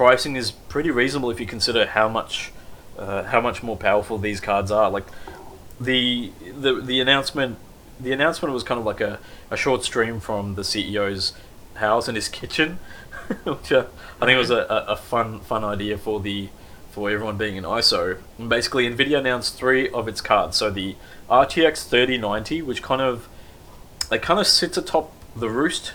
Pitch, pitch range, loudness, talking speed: 110 Hz, 100-125 Hz, -22 LUFS, 185 wpm